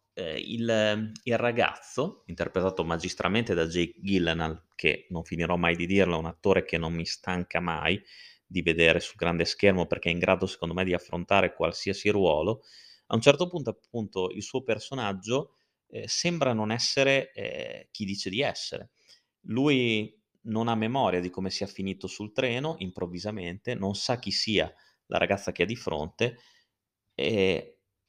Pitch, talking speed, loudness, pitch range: 100 Hz, 160 wpm, -28 LUFS, 90-115 Hz